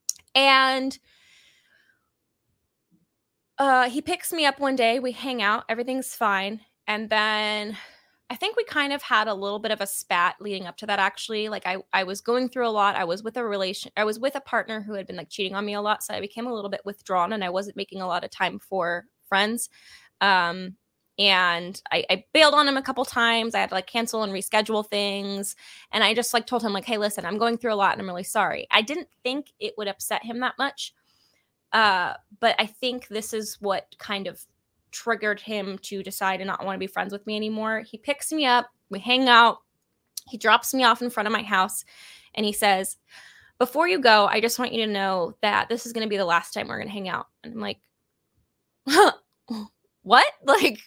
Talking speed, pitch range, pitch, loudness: 220 wpm, 200-245 Hz, 215 Hz, -24 LUFS